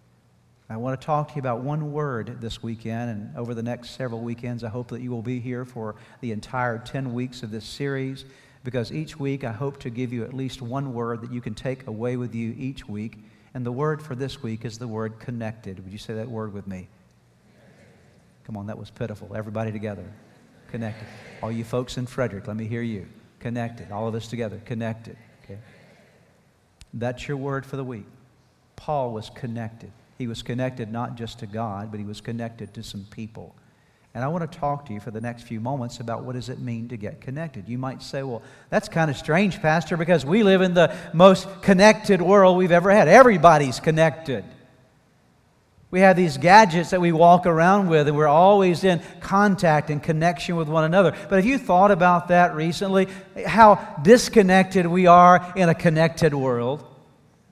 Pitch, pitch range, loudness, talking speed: 125 Hz, 115-165 Hz, -21 LUFS, 200 wpm